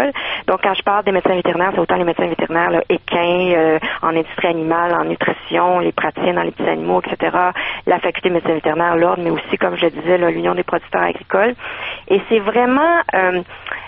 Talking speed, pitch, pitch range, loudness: 205 wpm, 180 Hz, 170-190 Hz, -17 LUFS